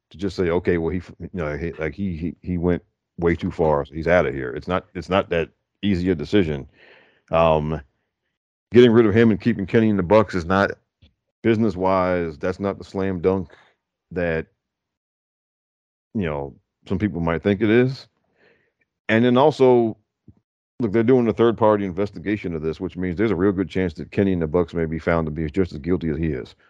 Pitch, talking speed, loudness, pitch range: 95 Hz, 210 wpm, -21 LUFS, 85-105 Hz